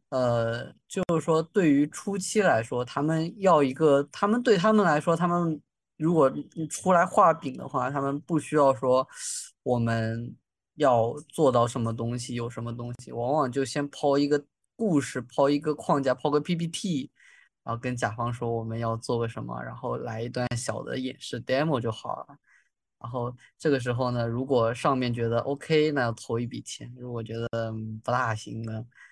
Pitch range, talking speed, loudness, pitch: 120-150 Hz, 265 characters per minute, -27 LUFS, 130 Hz